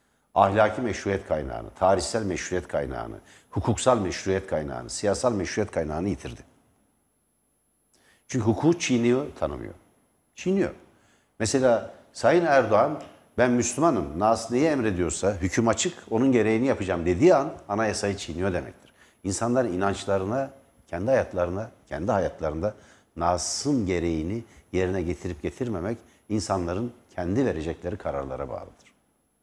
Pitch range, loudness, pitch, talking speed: 90-120 Hz, -26 LUFS, 105 Hz, 105 wpm